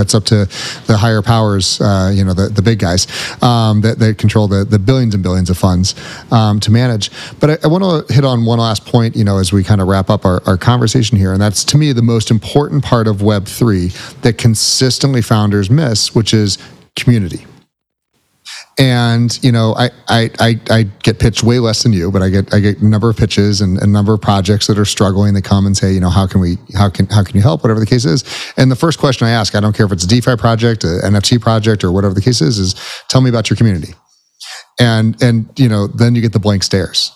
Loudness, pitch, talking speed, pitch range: -12 LUFS, 110 Hz, 245 wpm, 100-120 Hz